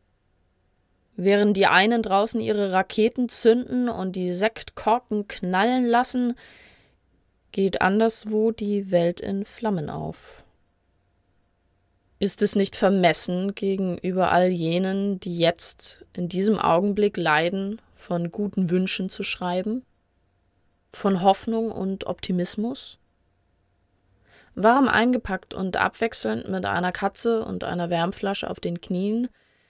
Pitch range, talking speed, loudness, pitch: 170-215 Hz, 110 wpm, -23 LUFS, 190 Hz